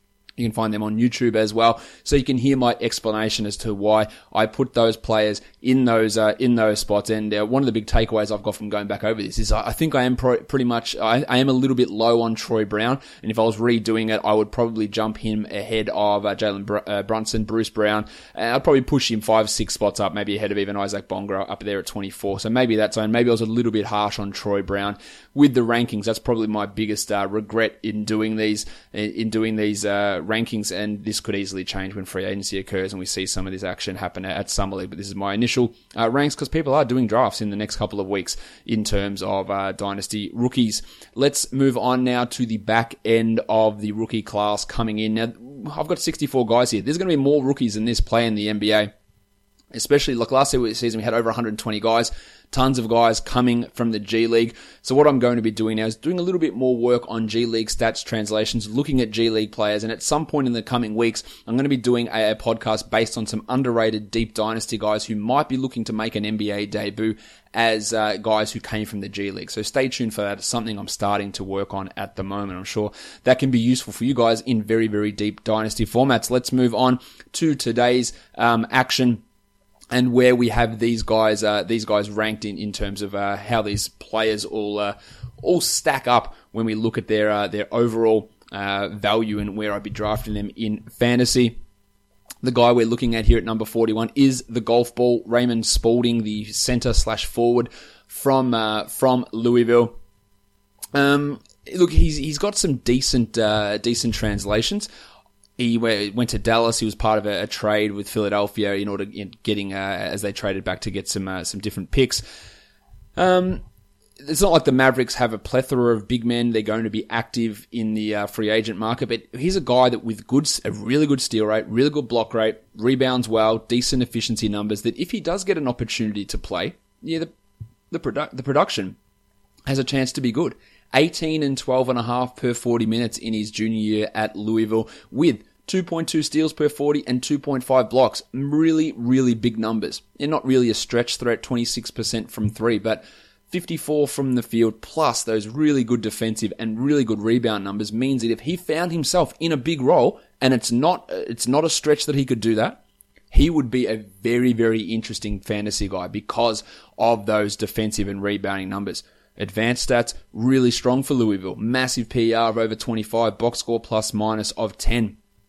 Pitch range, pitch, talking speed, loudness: 105-125 Hz, 110 Hz, 220 wpm, -22 LUFS